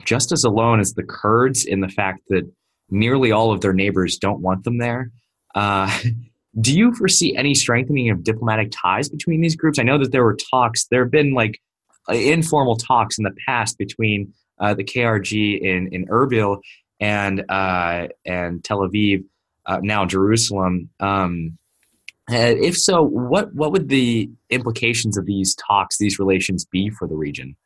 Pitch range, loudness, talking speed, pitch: 95-120 Hz, -19 LUFS, 170 wpm, 110 Hz